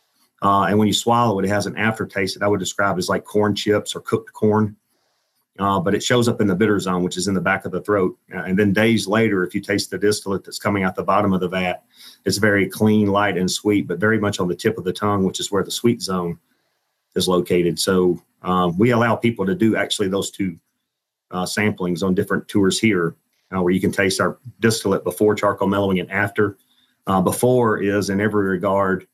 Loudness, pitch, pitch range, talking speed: -20 LUFS, 100 Hz, 95-105 Hz, 235 wpm